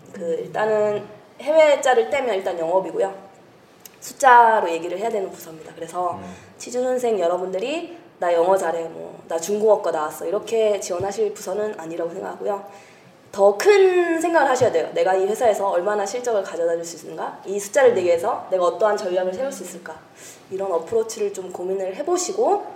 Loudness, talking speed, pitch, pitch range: -21 LUFS, 385 characters per minute, 200 Hz, 180-240 Hz